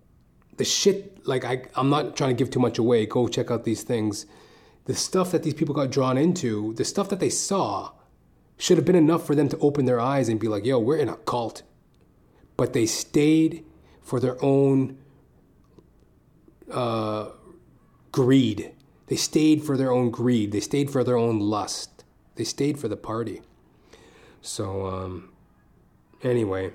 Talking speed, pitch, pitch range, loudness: 170 wpm, 130 Hz, 115-145 Hz, -24 LUFS